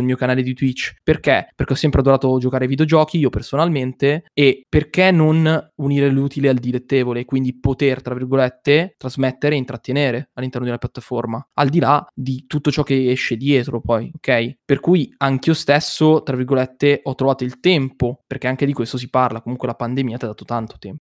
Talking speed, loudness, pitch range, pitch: 195 wpm, -18 LUFS, 125-145 Hz, 135 Hz